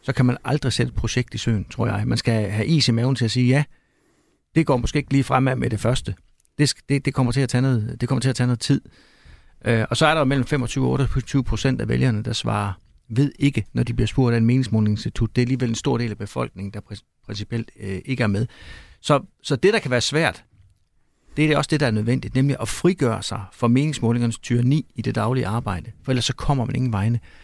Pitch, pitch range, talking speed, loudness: 120 Hz, 110-130 Hz, 255 wpm, -22 LUFS